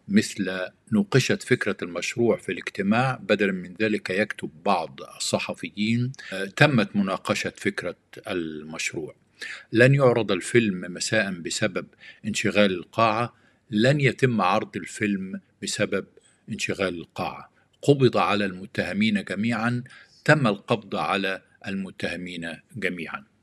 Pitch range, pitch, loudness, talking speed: 95-125 Hz, 105 Hz, -25 LUFS, 100 wpm